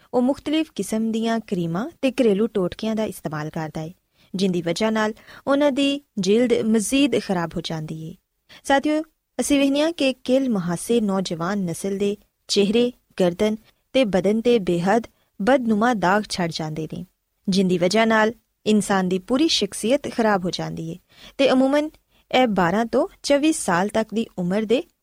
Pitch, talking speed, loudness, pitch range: 215 Hz, 155 wpm, -21 LUFS, 185-255 Hz